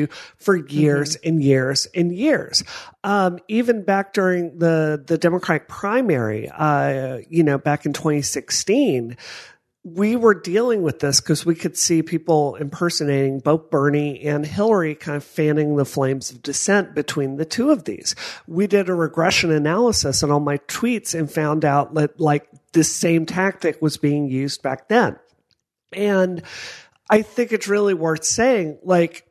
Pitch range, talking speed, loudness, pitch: 145-190 Hz, 160 wpm, -20 LUFS, 160 Hz